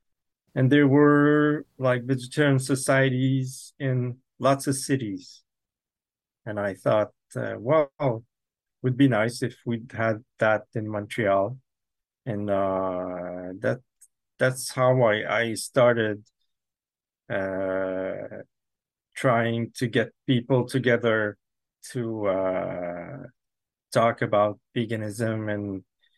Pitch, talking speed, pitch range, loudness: 120 Hz, 100 wpm, 105-130 Hz, -25 LUFS